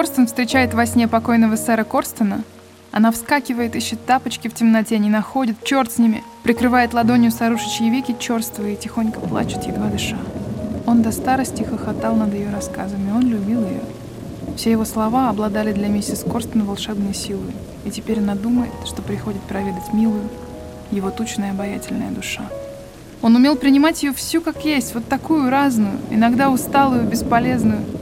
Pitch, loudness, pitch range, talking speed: 230 Hz, -19 LUFS, 215-250 Hz, 155 wpm